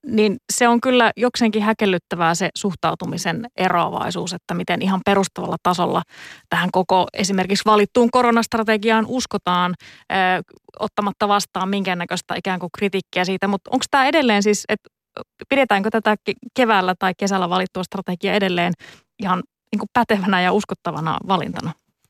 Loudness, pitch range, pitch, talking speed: -19 LUFS, 185-220 Hz, 200 Hz, 135 wpm